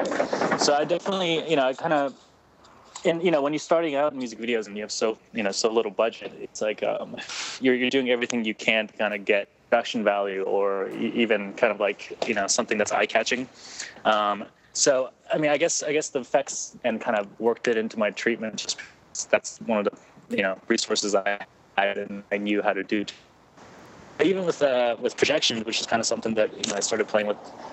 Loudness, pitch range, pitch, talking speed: -25 LUFS, 105-130 Hz, 115 Hz, 225 wpm